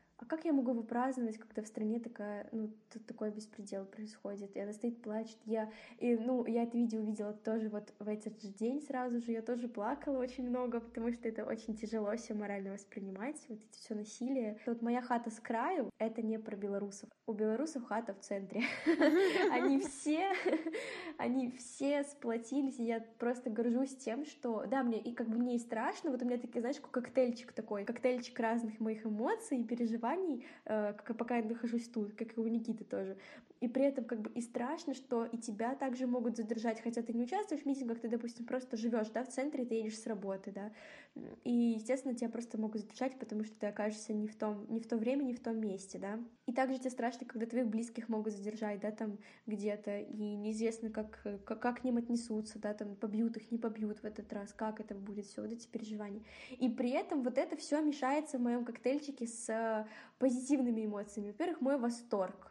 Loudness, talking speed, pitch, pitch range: -38 LUFS, 200 wpm, 235 Hz, 215-255 Hz